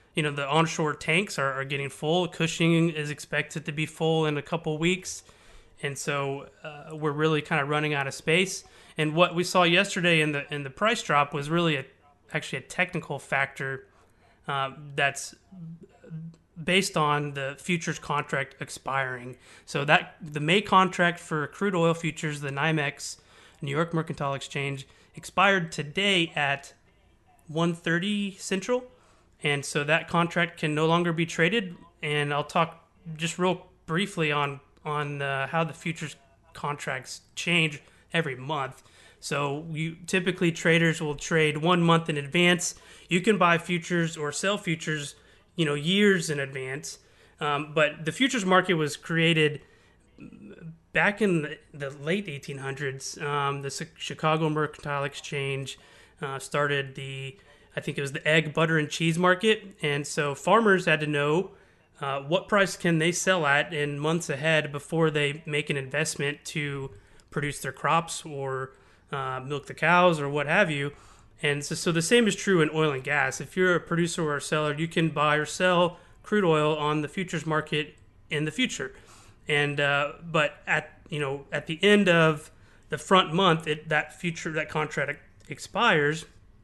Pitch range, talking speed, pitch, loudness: 145-170 Hz, 165 wpm, 155 Hz, -26 LUFS